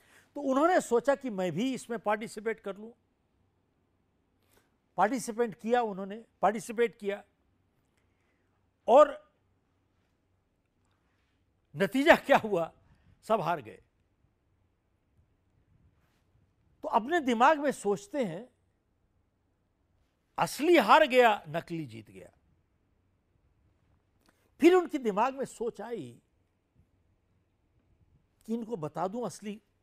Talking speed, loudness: 90 wpm, -28 LUFS